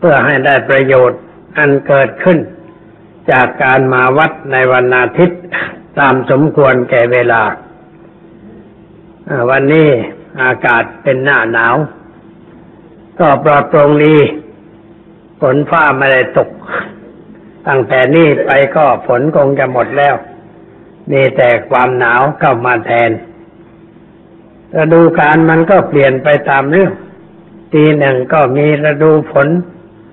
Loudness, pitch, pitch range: -10 LUFS, 145 Hz, 130-160 Hz